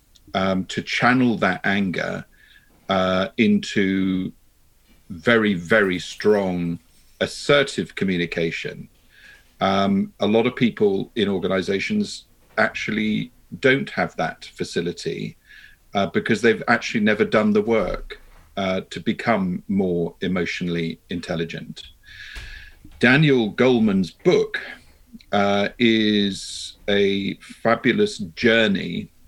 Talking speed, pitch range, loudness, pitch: 95 wpm, 95-125 Hz, -21 LUFS, 100 Hz